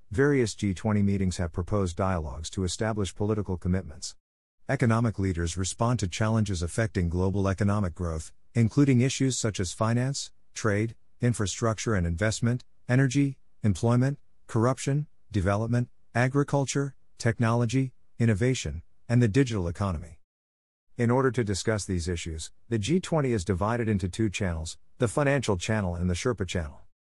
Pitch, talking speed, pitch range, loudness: 105 Hz, 130 wpm, 90-120 Hz, -28 LUFS